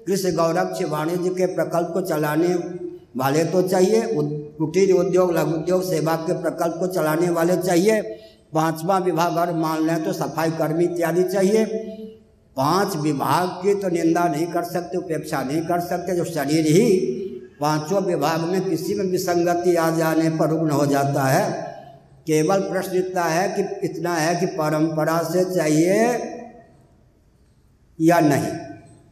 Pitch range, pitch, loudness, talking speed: 160-185 Hz, 175 Hz, -21 LUFS, 150 wpm